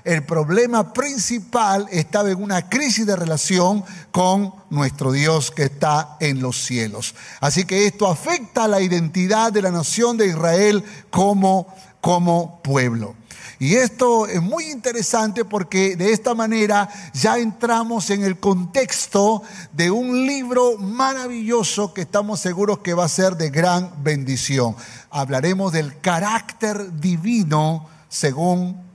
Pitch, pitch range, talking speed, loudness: 190 Hz, 160-220 Hz, 135 wpm, -19 LUFS